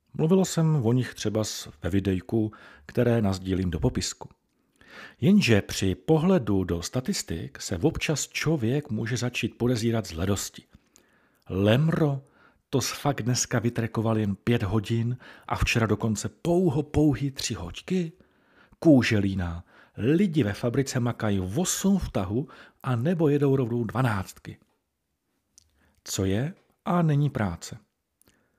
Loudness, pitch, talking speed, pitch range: -26 LUFS, 120 Hz, 120 wpm, 100-145 Hz